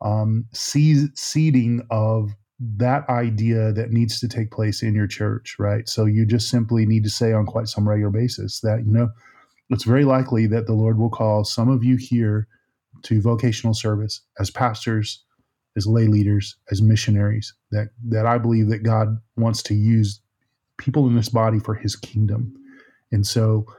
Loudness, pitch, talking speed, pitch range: -21 LUFS, 110 Hz, 175 wpm, 110-120 Hz